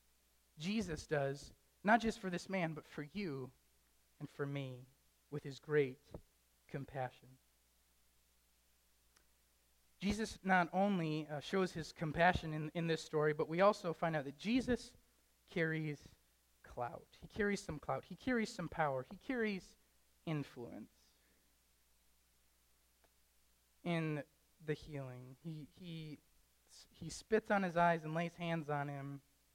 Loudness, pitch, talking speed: -39 LUFS, 145 Hz, 130 wpm